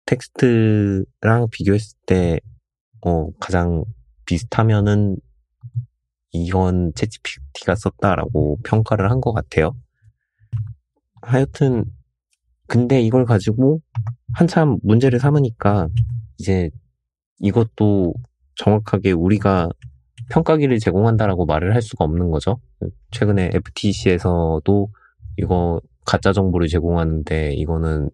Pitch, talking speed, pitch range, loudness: 100 Hz, 235 characters per minute, 85-115 Hz, -19 LUFS